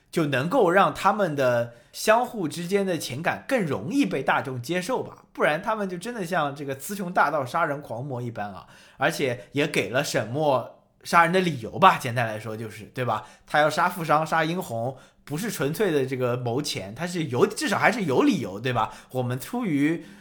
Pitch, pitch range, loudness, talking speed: 145 Hz, 120-180 Hz, -25 LUFS, 290 characters per minute